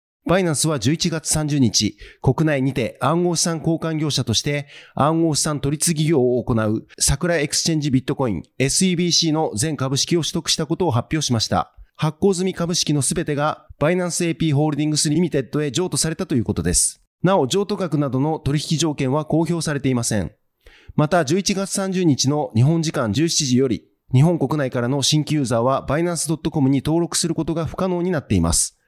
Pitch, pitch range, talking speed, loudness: 155 Hz, 135-170 Hz, 395 characters per minute, -20 LUFS